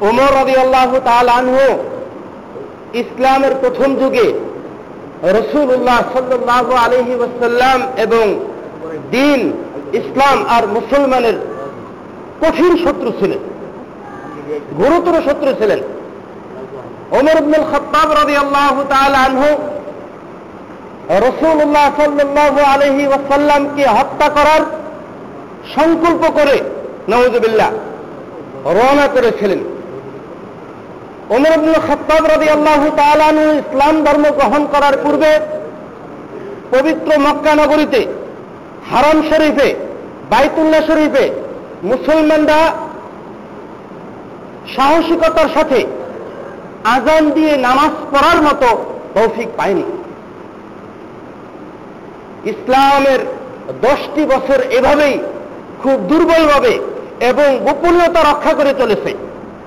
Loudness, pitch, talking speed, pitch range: -12 LUFS, 295 Hz, 75 wpm, 270-315 Hz